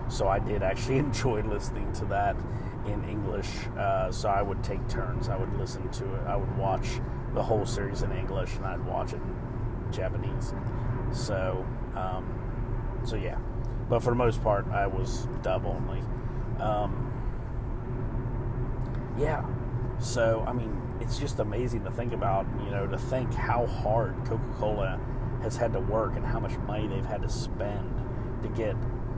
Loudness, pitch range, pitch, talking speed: -31 LUFS, 110-125 Hz, 120 Hz, 165 wpm